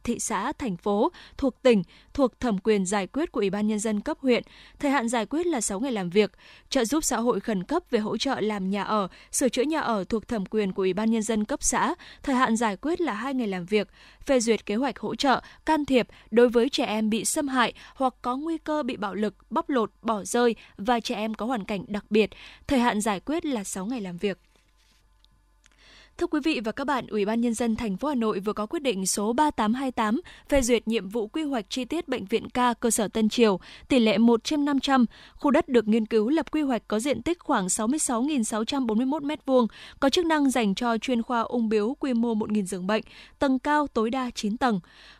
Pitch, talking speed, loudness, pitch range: 235 Hz, 240 wpm, -26 LUFS, 215-275 Hz